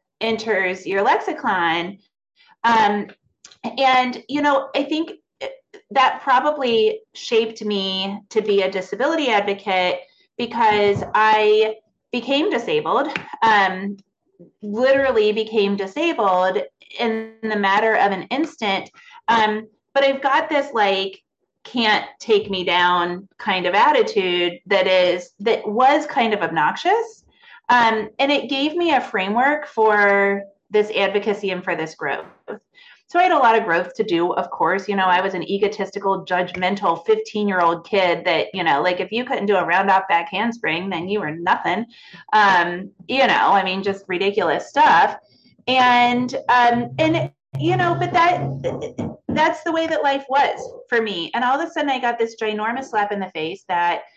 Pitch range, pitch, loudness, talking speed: 190-270 Hz, 215 Hz, -19 LUFS, 155 wpm